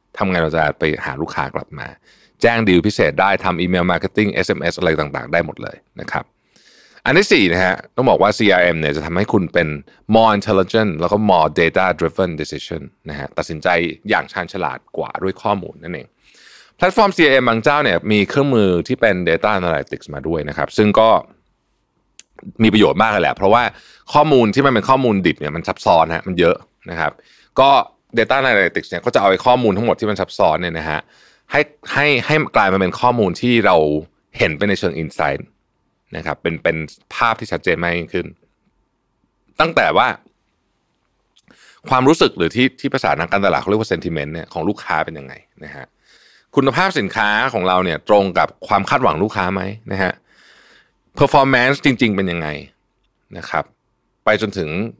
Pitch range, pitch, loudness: 85-115 Hz, 100 Hz, -16 LUFS